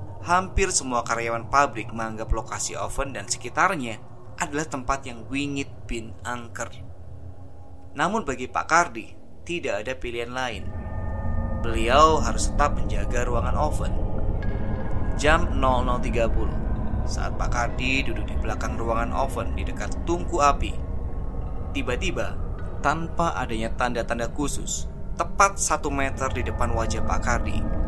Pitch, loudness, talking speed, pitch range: 110 Hz, -26 LUFS, 120 wpm, 95-125 Hz